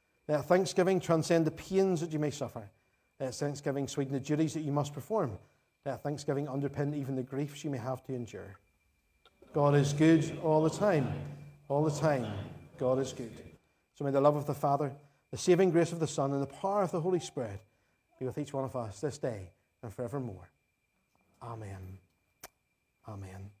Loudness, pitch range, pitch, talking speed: -32 LUFS, 120-155 Hz, 140 Hz, 185 wpm